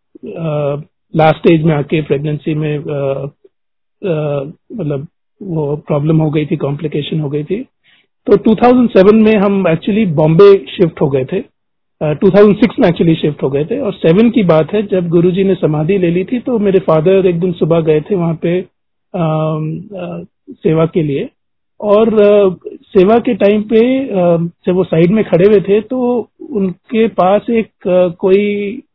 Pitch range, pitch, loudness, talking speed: 160-205 Hz, 185 Hz, -12 LUFS, 175 wpm